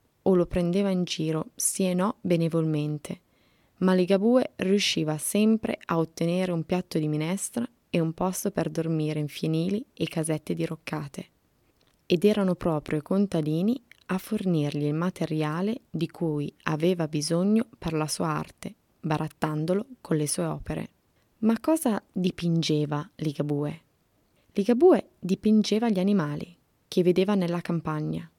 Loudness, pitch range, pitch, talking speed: -27 LUFS, 155-195 Hz, 175 Hz, 135 wpm